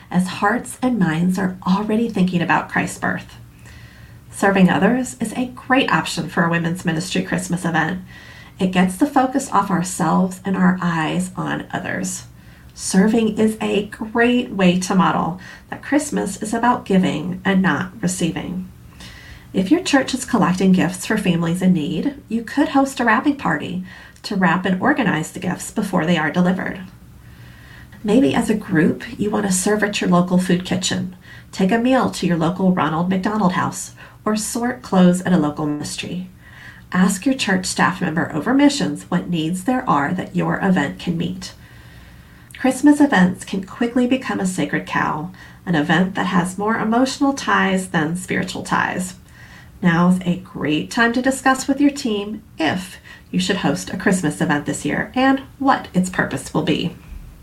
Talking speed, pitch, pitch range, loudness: 170 wpm, 190 Hz, 170-230 Hz, -19 LUFS